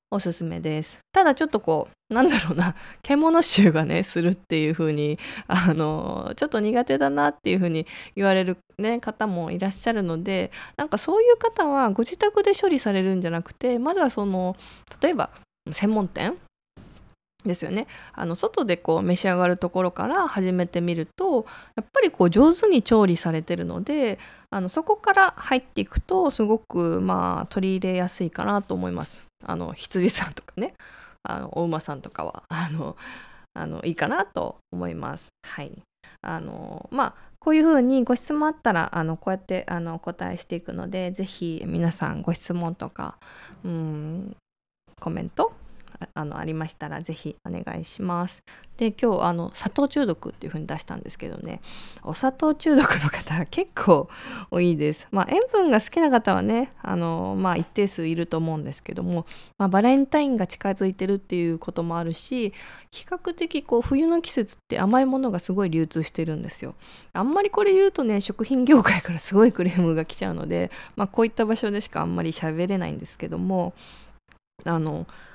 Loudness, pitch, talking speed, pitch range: -24 LUFS, 190 Hz, 330 characters per minute, 170-245 Hz